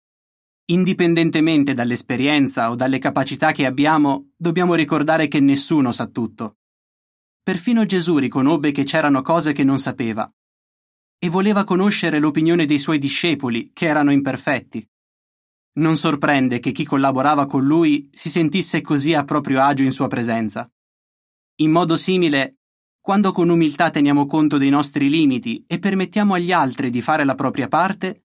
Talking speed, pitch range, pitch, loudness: 145 wpm, 135-170 Hz, 155 Hz, -18 LUFS